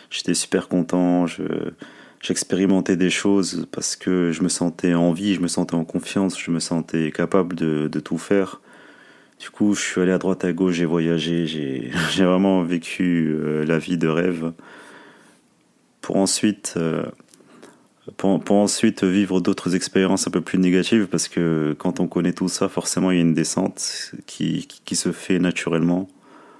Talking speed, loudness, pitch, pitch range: 175 wpm, -21 LUFS, 90 Hz, 85-95 Hz